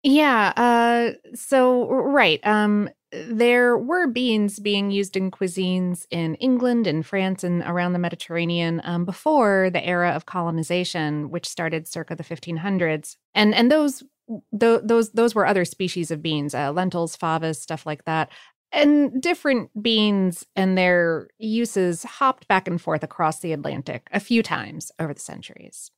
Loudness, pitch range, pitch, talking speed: -22 LUFS, 170-235 Hz, 190 Hz, 155 wpm